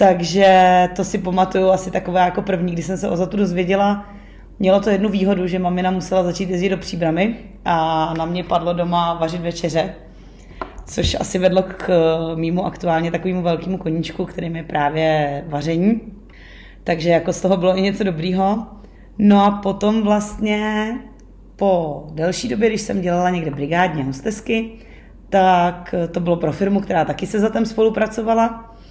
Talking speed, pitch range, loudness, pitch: 160 wpm, 170-200 Hz, -18 LUFS, 185 Hz